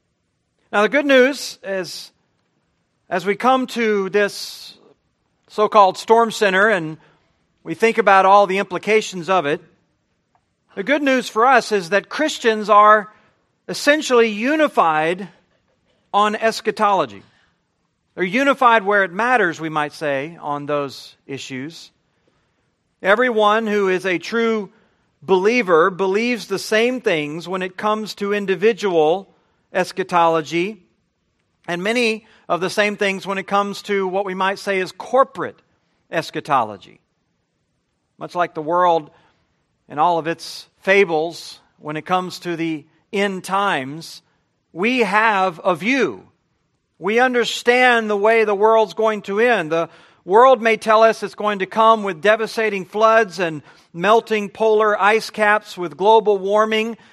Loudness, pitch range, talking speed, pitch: -17 LUFS, 180-220 Hz, 135 wpm, 205 Hz